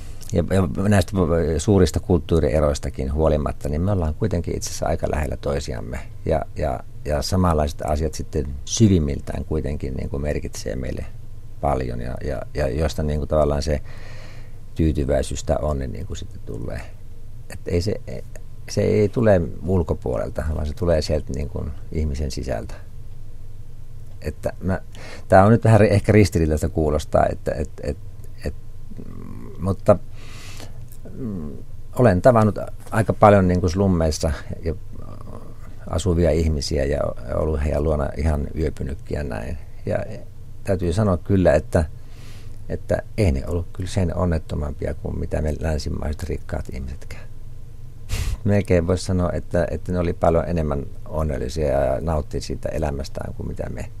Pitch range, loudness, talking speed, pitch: 75-105 Hz, -22 LUFS, 135 wpm, 90 Hz